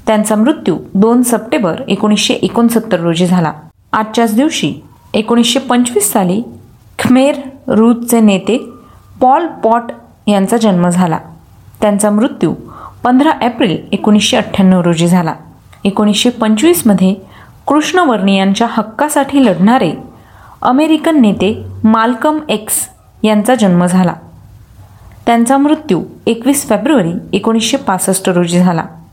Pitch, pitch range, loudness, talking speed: 220 Hz, 190-250 Hz, -11 LUFS, 105 wpm